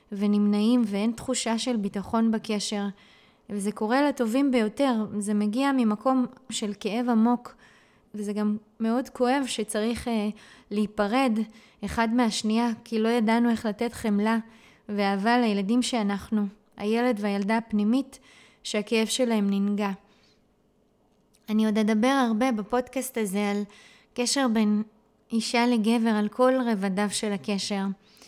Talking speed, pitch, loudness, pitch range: 120 wpm, 225 Hz, -26 LUFS, 210-240 Hz